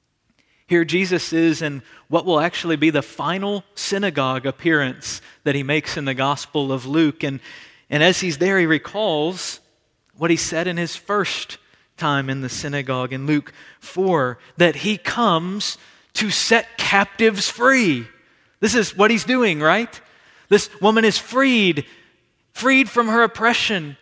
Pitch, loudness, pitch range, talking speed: 170 Hz, -19 LUFS, 145-205 Hz, 150 wpm